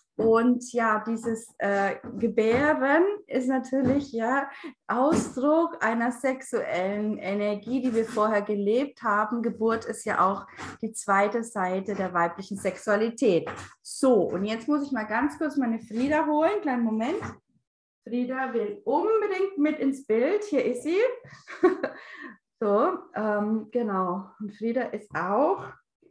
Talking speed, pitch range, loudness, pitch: 130 wpm, 215-270 Hz, -26 LUFS, 230 Hz